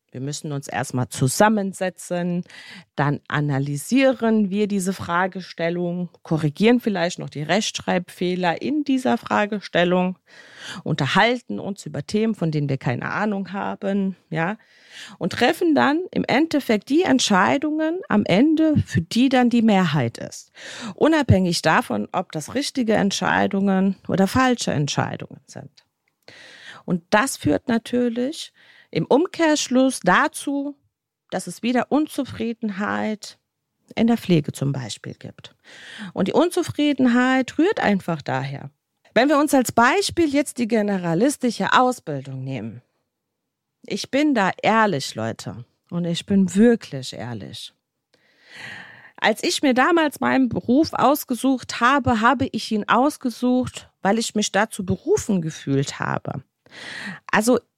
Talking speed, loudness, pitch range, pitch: 120 wpm, -21 LUFS, 170-255 Hz, 205 Hz